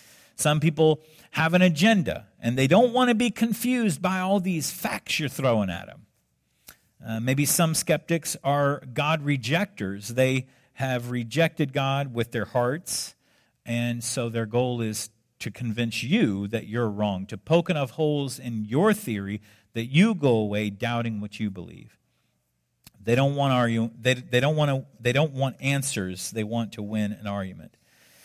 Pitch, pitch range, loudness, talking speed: 130 Hz, 115-155 Hz, -25 LUFS, 170 wpm